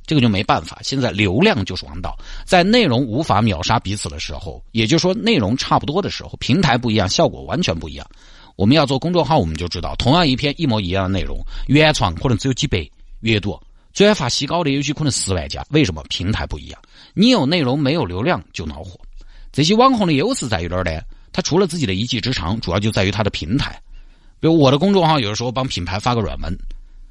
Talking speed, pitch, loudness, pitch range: 360 characters per minute, 110 Hz, -18 LUFS, 95-145 Hz